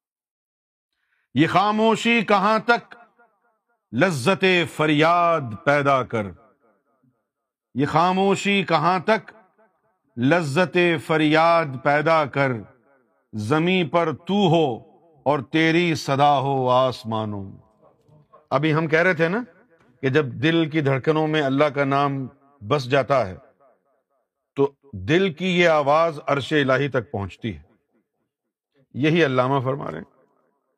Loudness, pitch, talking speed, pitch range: -20 LUFS, 150 Hz, 115 wpm, 135-175 Hz